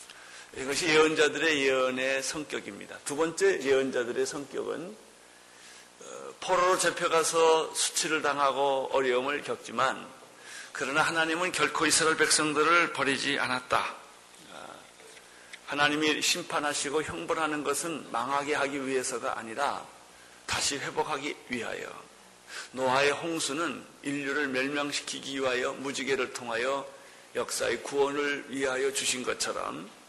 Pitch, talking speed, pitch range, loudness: 145 Hz, 285 characters per minute, 130-155 Hz, -28 LUFS